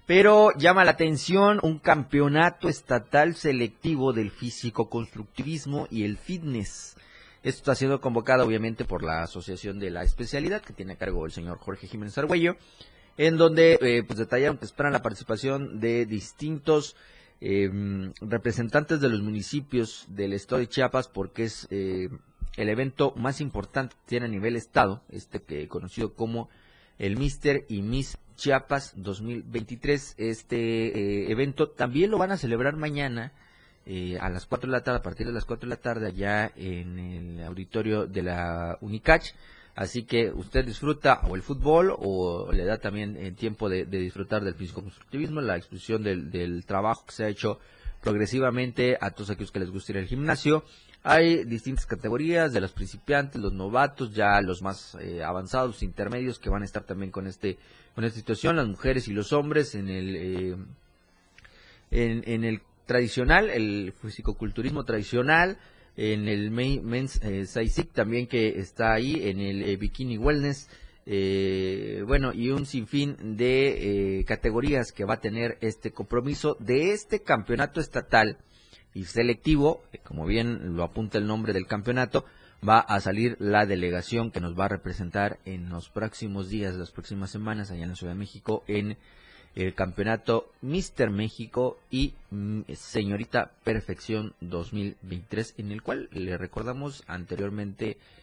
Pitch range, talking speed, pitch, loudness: 100-130 Hz, 160 wpm, 110 Hz, -27 LUFS